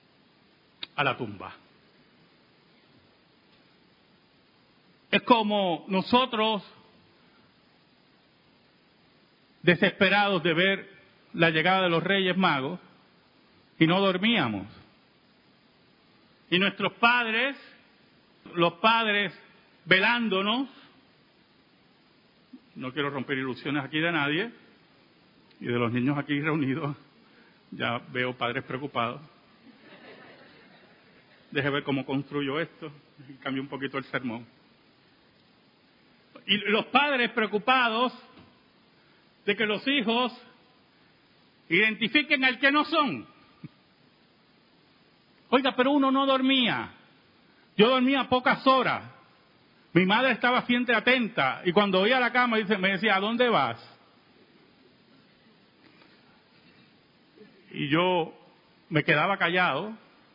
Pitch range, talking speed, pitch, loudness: 160-245 Hz, 95 wpm, 200 Hz, -25 LUFS